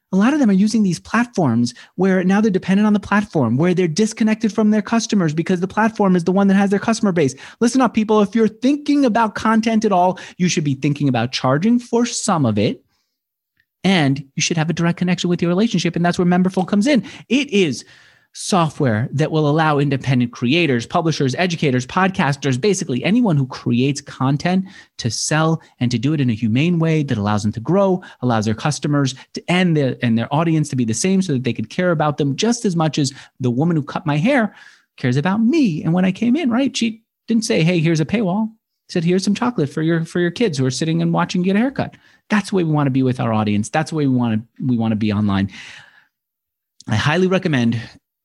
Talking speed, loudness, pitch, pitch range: 235 wpm, -18 LUFS, 170 Hz, 135-205 Hz